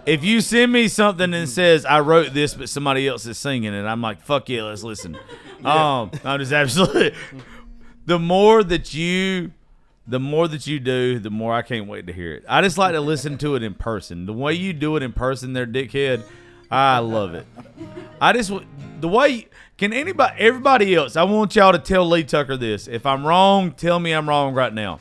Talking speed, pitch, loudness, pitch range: 215 wpm, 145 Hz, -19 LUFS, 125-175 Hz